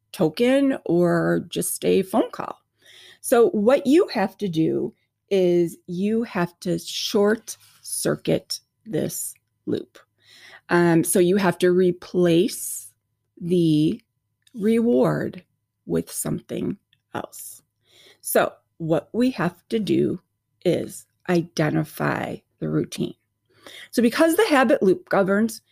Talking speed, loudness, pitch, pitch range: 110 wpm, -22 LUFS, 175 Hz, 155-210 Hz